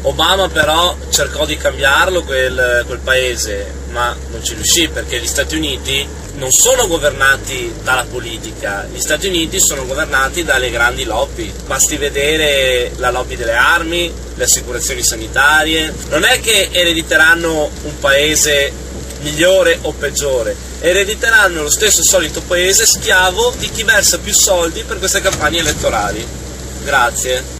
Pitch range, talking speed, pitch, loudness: 120-180 Hz, 135 wpm, 150 Hz, -13 LUFS